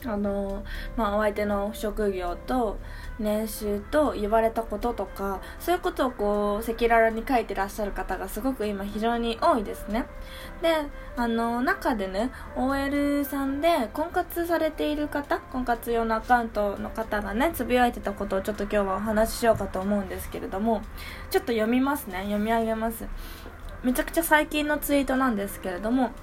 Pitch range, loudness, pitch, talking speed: 205-275 Hz, -27 LUFS, 230 Hz, 355 characters per minute